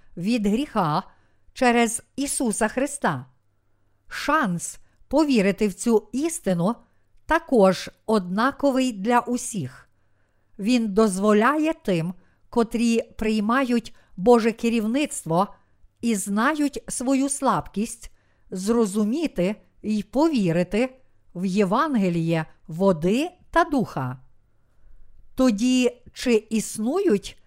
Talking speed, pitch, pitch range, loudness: 80 wpm, 220 Hz, 185-250 Hz, -23 LUFS